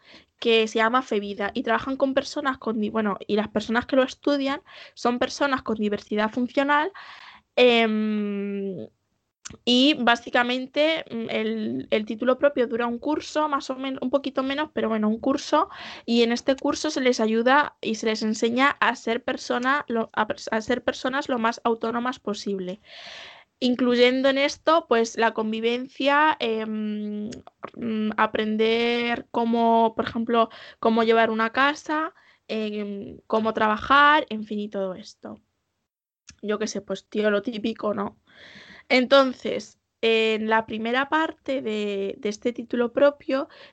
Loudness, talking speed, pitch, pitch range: -24 LUFS, 140 wpm, 235 Hz, 220-270 Hz